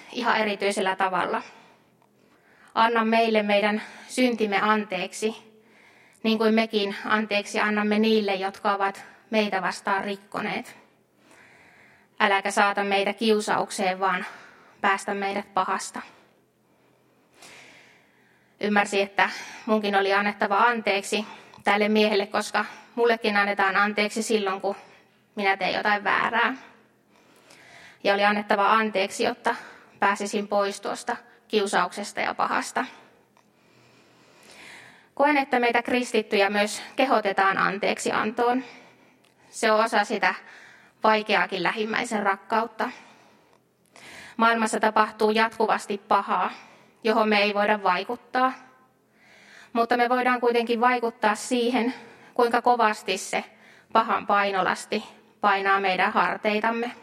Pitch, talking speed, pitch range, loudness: 215 Hz, 100 wpm, 200-225 Hz, -24 LUFS